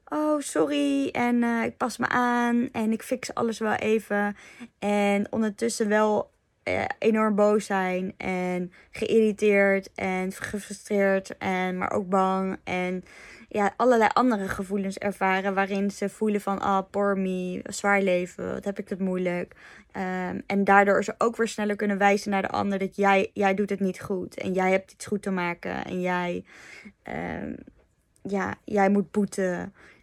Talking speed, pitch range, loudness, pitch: 165 wpm, 190-215 Hz, -26 LUFS, 200 Hz